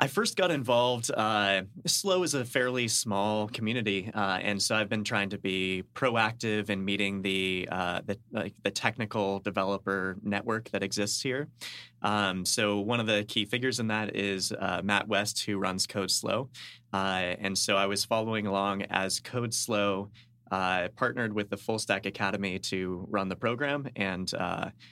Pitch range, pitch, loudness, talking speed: 95-115 Hz, 105 Hz, -29 LUFS, 175 wpm